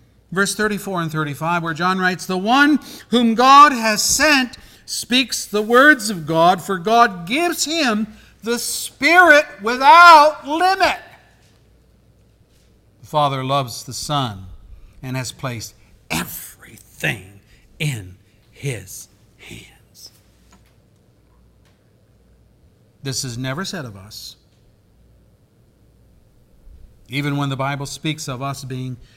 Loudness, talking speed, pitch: -16 LUFS, 105 wpm, 135 Hz